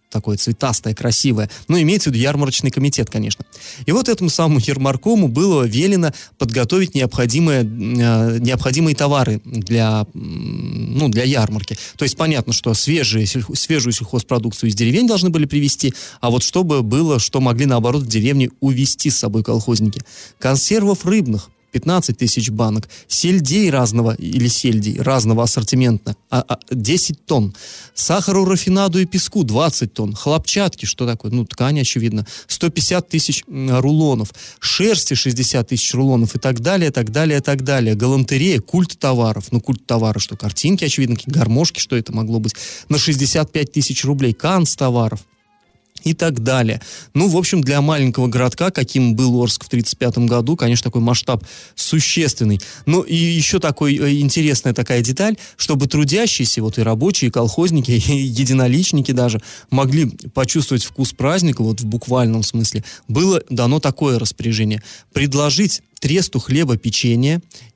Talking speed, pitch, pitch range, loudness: 145 wpm, 130 Hz, 115-155 Hz, -17 LUFS